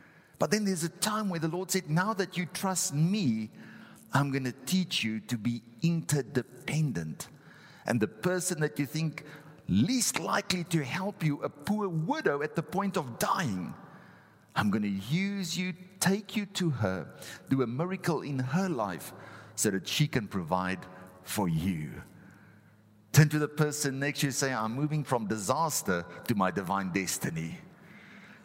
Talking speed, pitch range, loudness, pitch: 165 wpm, 120-185 Hz, -31 LUFS, 150 Hz